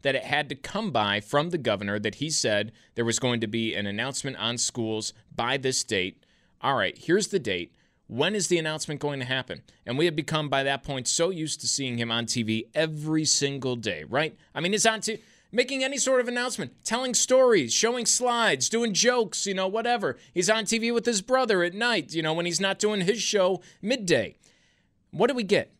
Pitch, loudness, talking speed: 155 Hz, -26 LUFS, 220 wpm